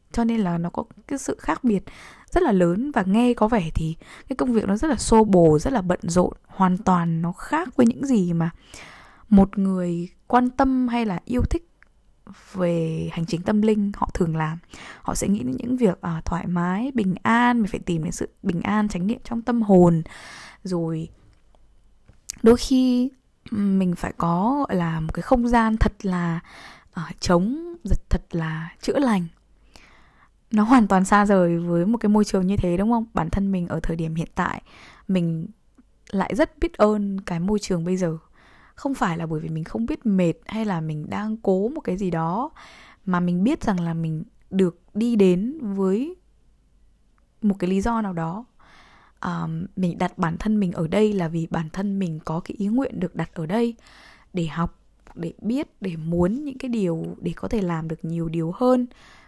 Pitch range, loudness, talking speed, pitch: 170-230 Hz, -23 LUFS, 200 wpm, 190 Hz